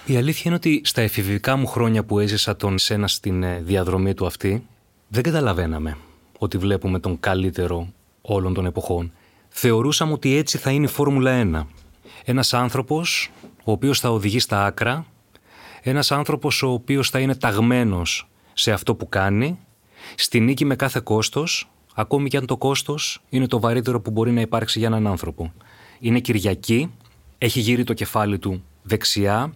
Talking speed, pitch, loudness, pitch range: 160 wpm, 115 Hz, -21 LUFS, 100-130 Hz